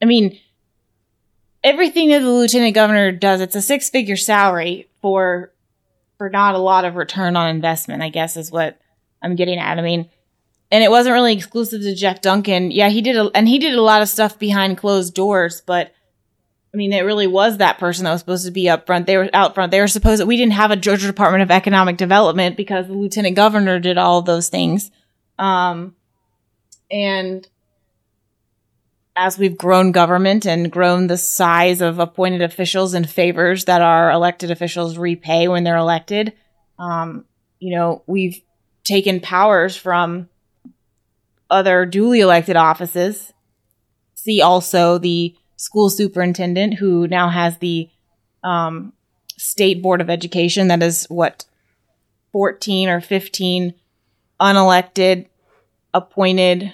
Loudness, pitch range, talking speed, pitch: -16 LUFS, 170-195 Hz, 160 wpm, 180 Hz